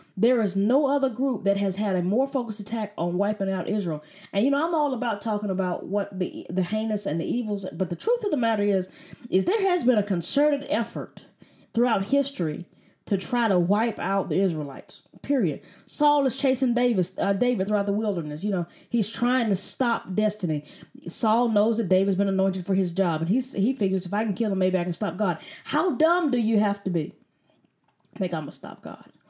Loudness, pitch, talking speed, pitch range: -25 LUFS, 205 Hz, 220 wpm, 190-245 Hz